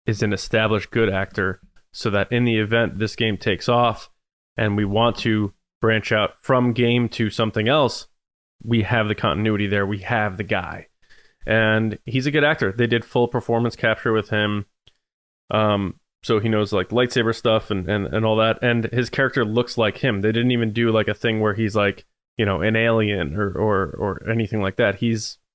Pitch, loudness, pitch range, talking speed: 110 Hz, -21 LUFS, 105-115 Hz, 200 wpm